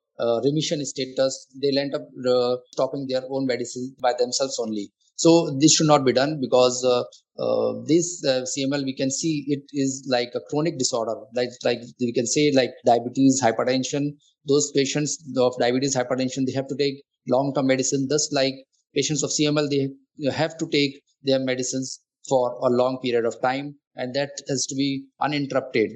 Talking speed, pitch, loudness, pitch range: 180 wpm, 135 Hz, -23 LUFS, 130-145 Hz